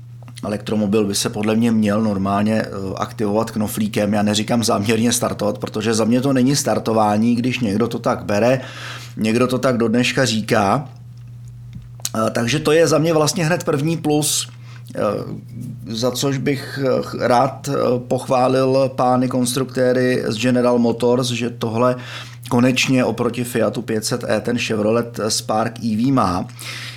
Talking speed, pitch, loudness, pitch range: 135 wpm, 120 Hz, -18 LUFS, 110-125 Hz